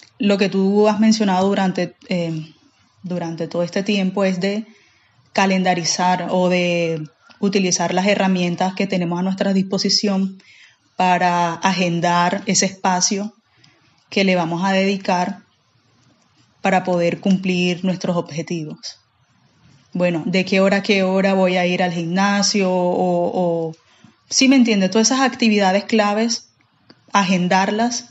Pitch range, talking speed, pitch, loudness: 175-200 Hz, 130 wpm, 190 Hz, -18 LUFS